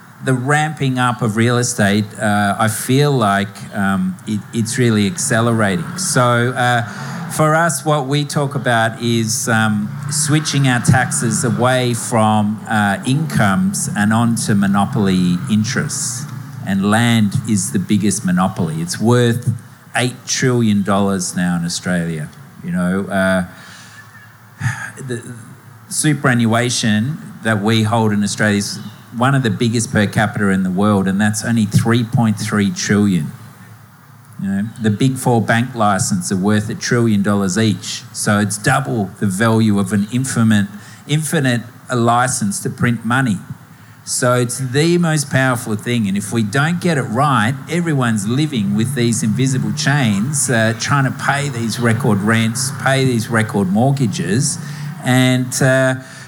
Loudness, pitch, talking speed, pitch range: -16 LUFS, 115 Hz, 140 wpm, 105-130 Hz